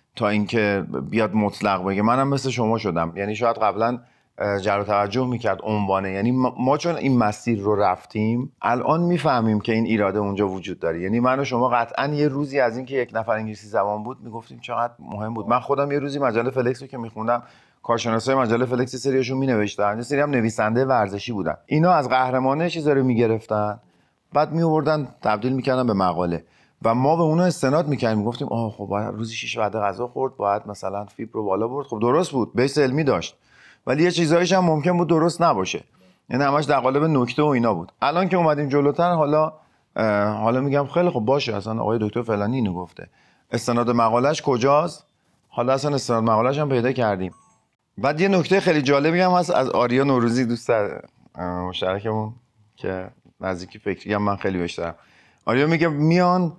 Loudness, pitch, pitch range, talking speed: -22 LUFS, 120 Hz, 105-140 Hz, 180 wpm